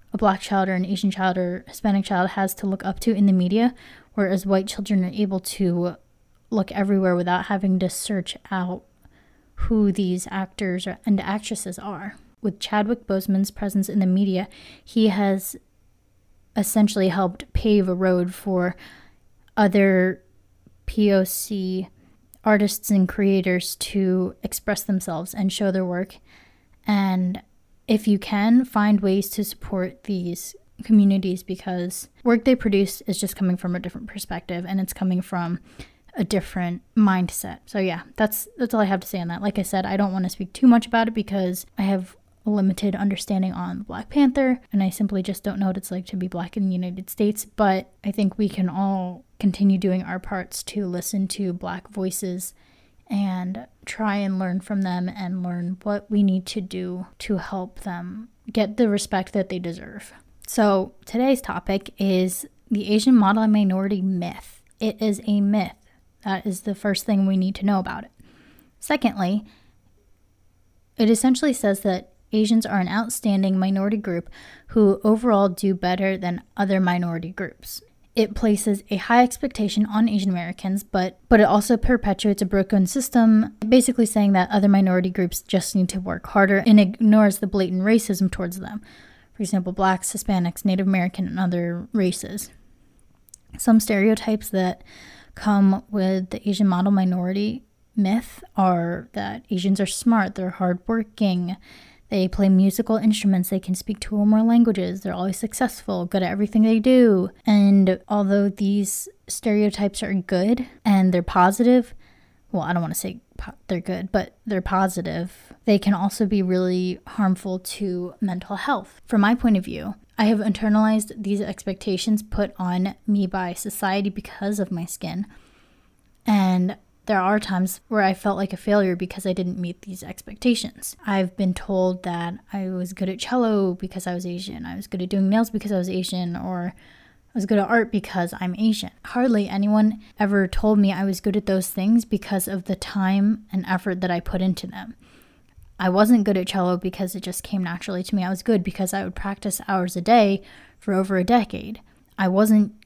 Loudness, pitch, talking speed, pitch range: -22 LUFS, 195 Hz, 175 wpm, 185-210 Hz